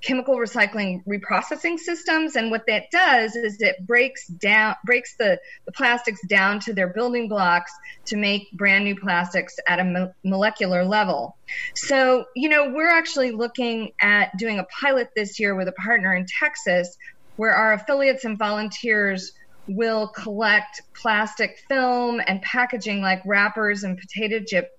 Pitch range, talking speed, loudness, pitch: 200-250 Hz, 155 wpm, -21 LUFS, 215 Hz